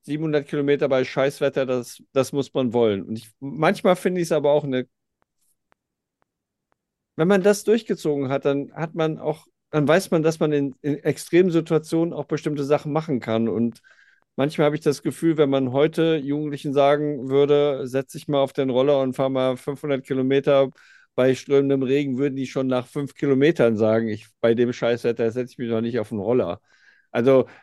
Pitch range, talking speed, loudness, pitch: 130-150 Hz, 190 wpm, -22 LUFS, 140 Hz